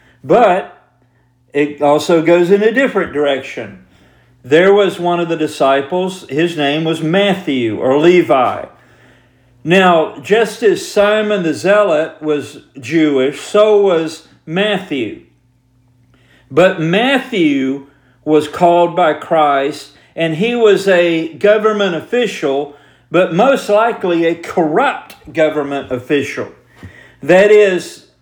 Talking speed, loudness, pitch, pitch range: 110 wpm, -13 LUFS, 160 Hz, 140-190 Hz